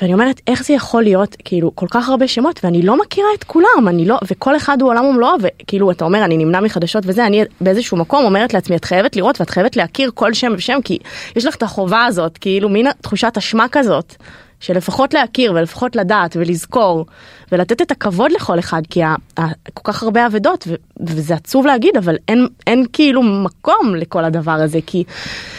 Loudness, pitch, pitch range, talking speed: -14 LUFS, 205 Hz, 175-245 Hz, 200 wpm